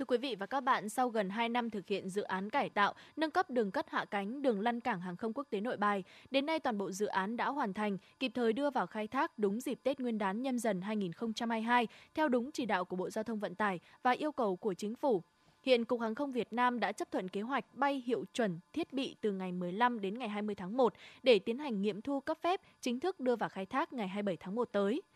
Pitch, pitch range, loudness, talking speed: 230 Hz, 205-265 Hz, -35 LUFS, 265 wpm